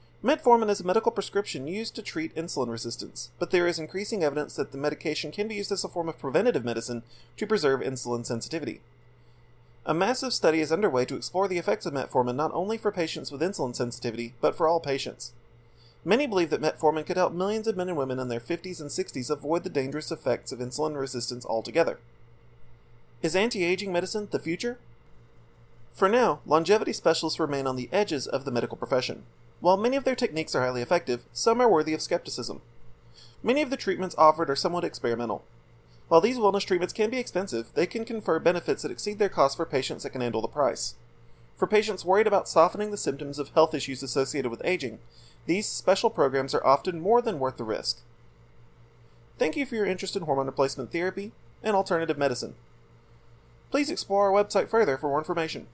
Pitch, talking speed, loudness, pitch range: 155 Hz, 195 wpm, -27 LUFS, 120-190 Hz